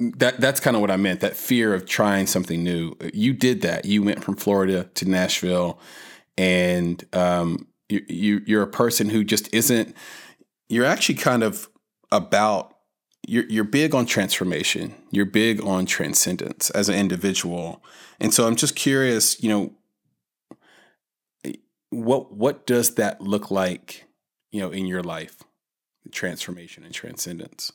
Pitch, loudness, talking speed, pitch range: 100 Hz, -22 LUFS, 150 wpm, 90-115 Hz